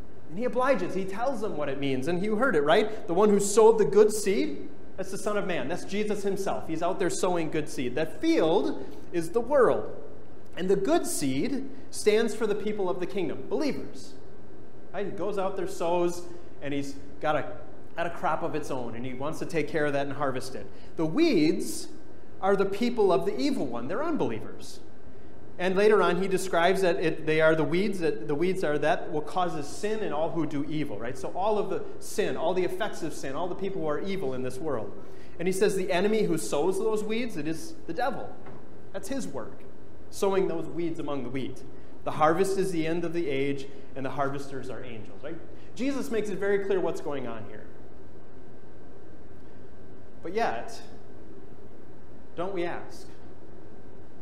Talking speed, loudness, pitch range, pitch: 205 wpm, -28 LUFS, 150-210 Hz, 175 Hz